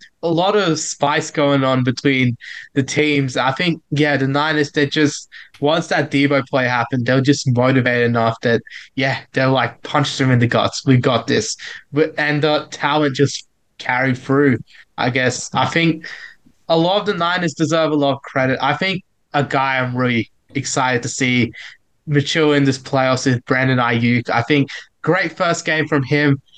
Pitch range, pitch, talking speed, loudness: 130-150 Hz, 140 Hz, 185 wpm, -17 LUFS